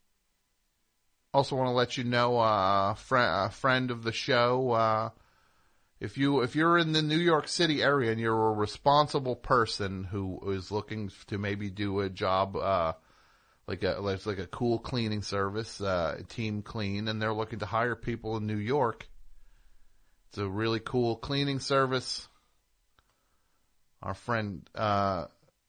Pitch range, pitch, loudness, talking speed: 100-125 Hz, 110 Hz, -29 LUFS, 155 wpm